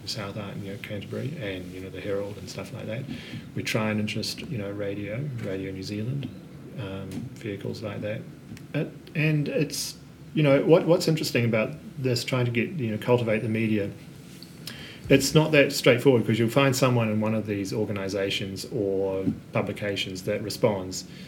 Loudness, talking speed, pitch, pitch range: -26 LUFS, 175 wpm, 110 Hz, 100-135 Hz